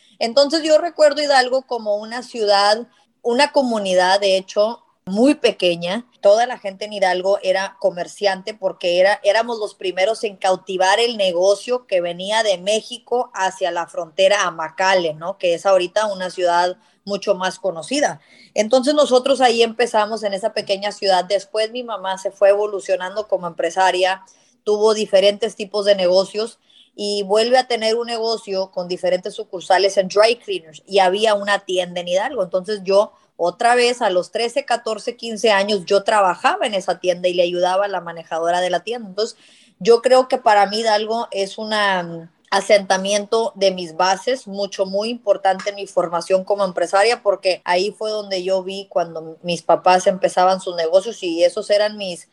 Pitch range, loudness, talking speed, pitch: 185-225 Hz, -18 LUFS, 170 wpm, 200 Hz